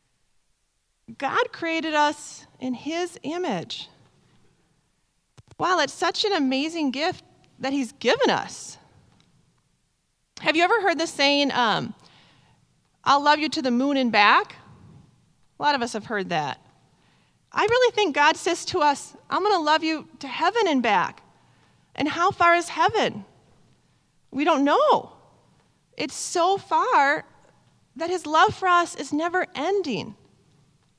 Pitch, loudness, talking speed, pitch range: 320 Hz, -23 LUFS, 140 wpm, 280-360 Hz